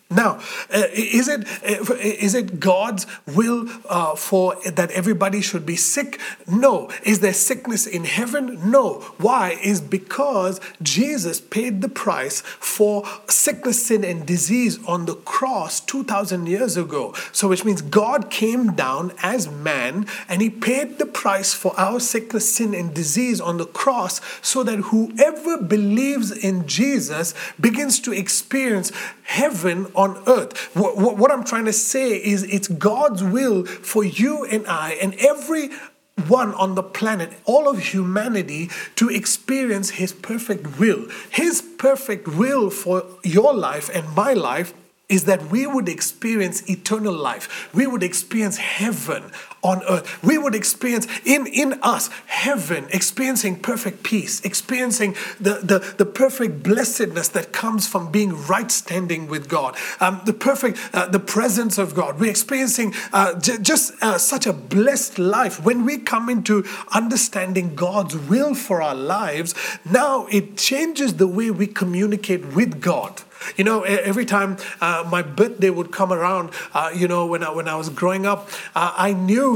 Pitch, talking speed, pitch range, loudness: 205 Hz, 160 wpm, 185-240 Hz, -20 LUFS